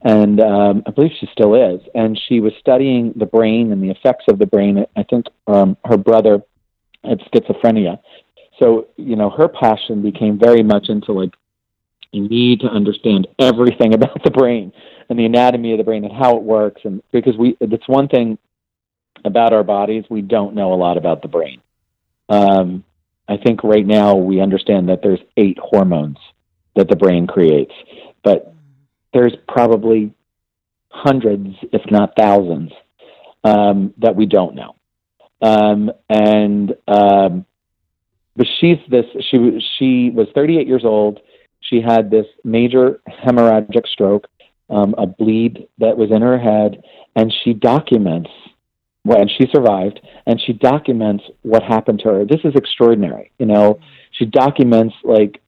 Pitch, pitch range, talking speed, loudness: 110 Hz, 100-120 Hz, 160 wpm, -14 LUFS